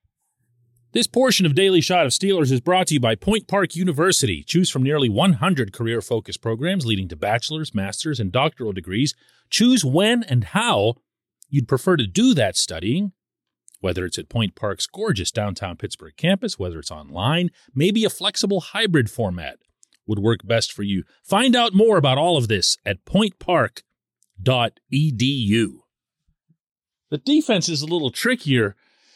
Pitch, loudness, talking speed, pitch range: 140 Hz, -20 LUFS, 155 wpm, 110-185 Hz